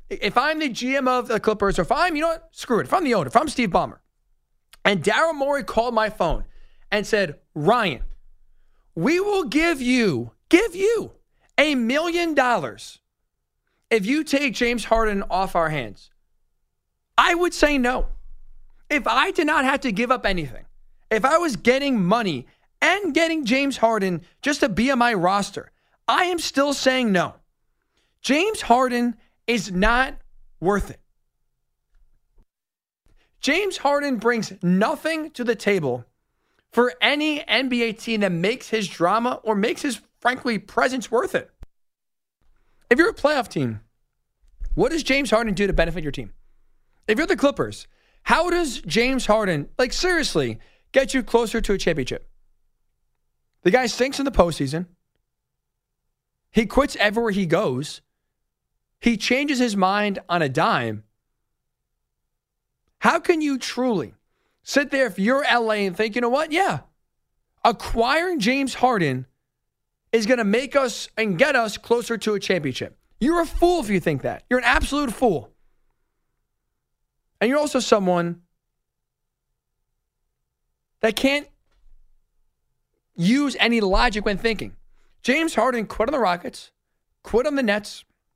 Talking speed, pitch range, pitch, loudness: 150 wpm, 185-275 Hz, 230 Hz, -21 LUFS